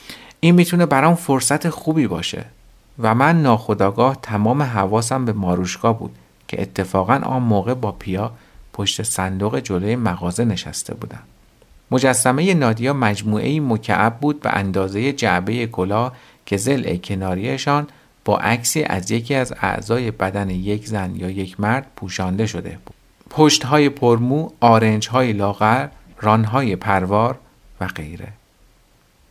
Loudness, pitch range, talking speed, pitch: -19 LUFS, 100-130 Hz, 130 wpm, 110 Hz